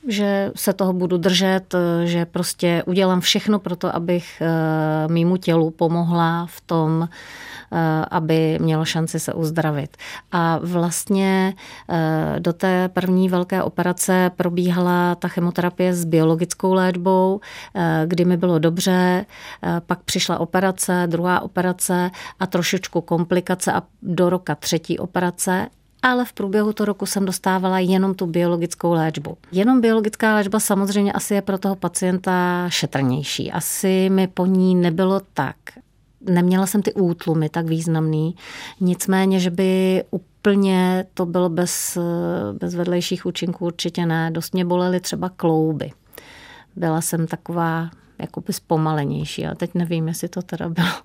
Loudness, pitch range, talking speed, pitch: -20 LUFS, 170-190 Hz, 135 wpm, 180 Hz